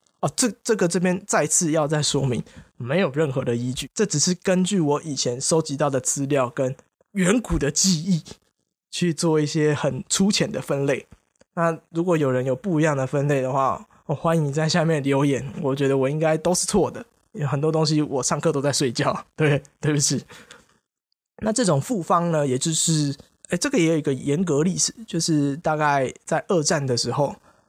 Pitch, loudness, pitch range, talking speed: 155 Hz, -22 LUFS, 140-175 Hz, 275 characters per minute